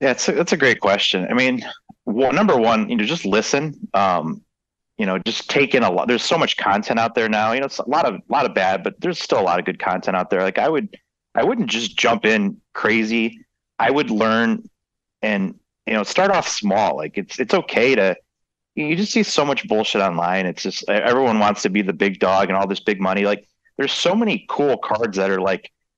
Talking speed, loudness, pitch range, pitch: 240 wpm, -19 LUFS, 100-160 Hz, 110 Hz